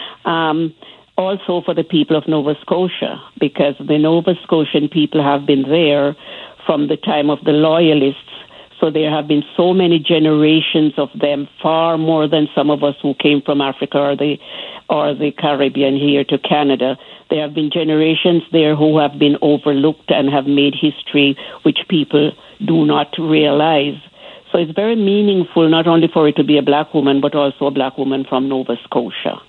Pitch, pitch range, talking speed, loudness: 150 Hz, 145-160 Hz, 180 wpm, -15 LUFS